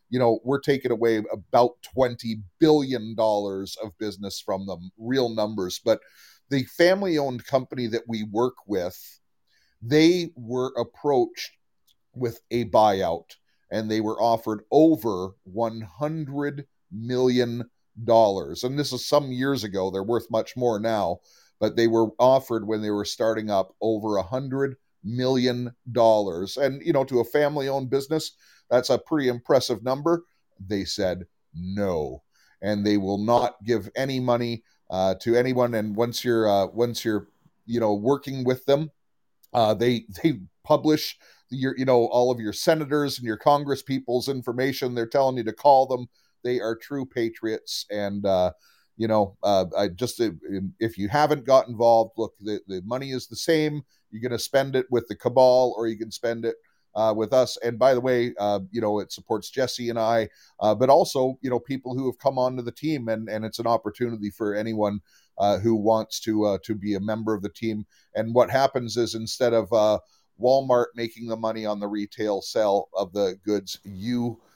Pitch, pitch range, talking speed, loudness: 115 Hz, 110-130 Hz, 175 wpm, -24 LUFS